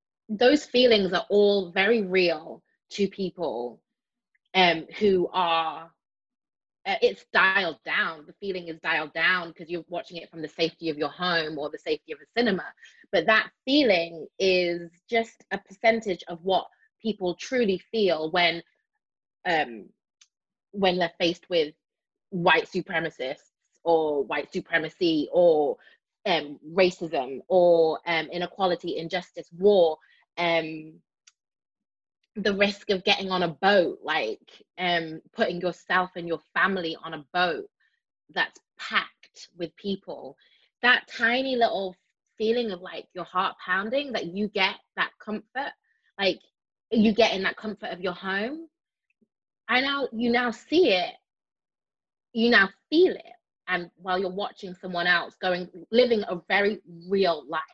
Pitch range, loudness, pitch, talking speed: 170-225 Hz, -25 LUFS, 185 Hz, 140 wpm